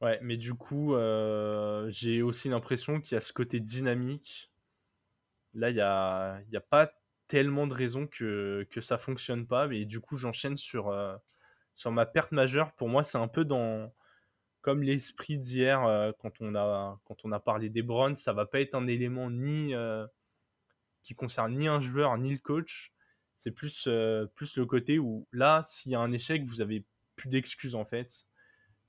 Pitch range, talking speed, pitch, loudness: 110-135 Hz, 190 wpm, 120 Hz, -32 LUFS